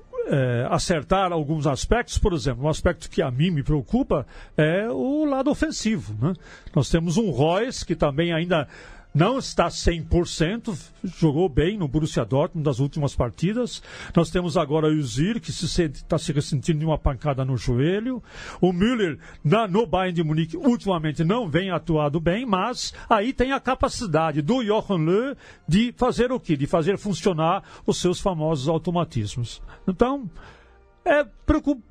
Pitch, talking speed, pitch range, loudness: 175 Hz, 160 wpm, 155-215 Hz, -23 LUFS